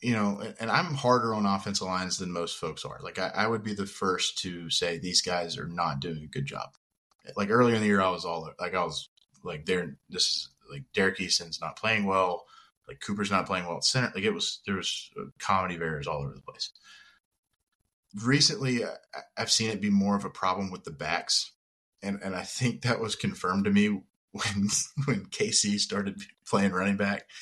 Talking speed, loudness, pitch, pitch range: 210 wpm, -28 LUFS, 100 Hz, 95-115 Hz